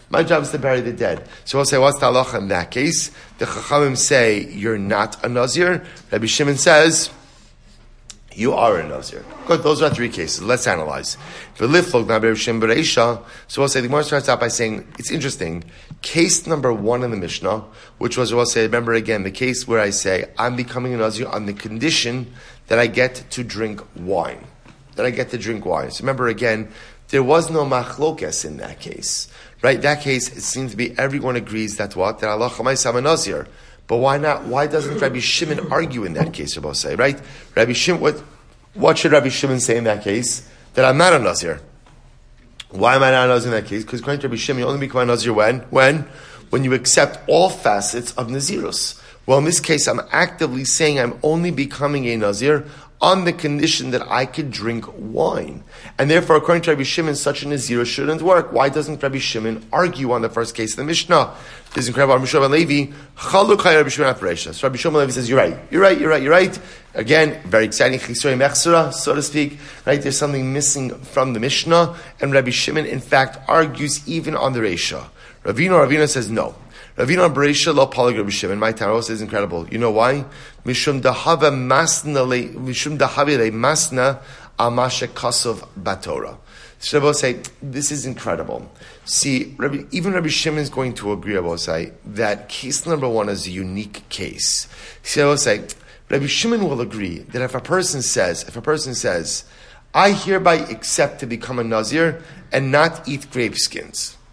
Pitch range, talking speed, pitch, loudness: 120-150 Hz, 190 wpm, 130 Hz, -18 LUFS